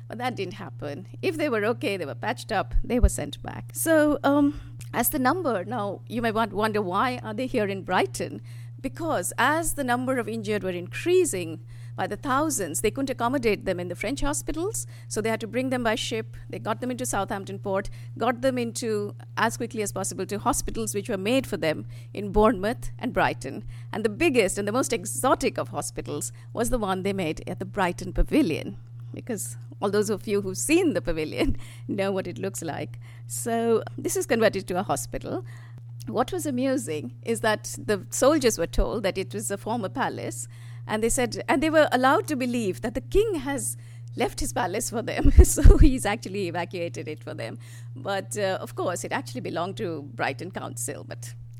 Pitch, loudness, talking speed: 175 Hz, -26 LUFS, 200 wpm